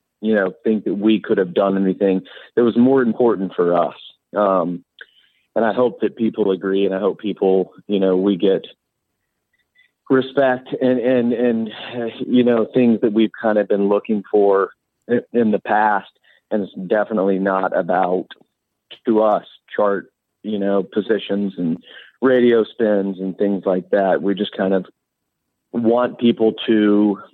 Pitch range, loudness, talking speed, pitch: 95-120 Hz, -18 LUFS, 160 wpm, 105 Hz